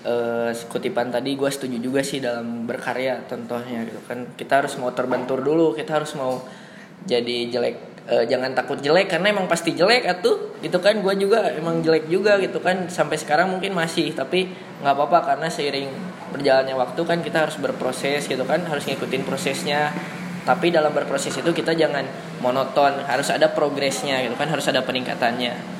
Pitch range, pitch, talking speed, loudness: 130-175 Hz, 150 Hz, 175 wpm, -22 LUFS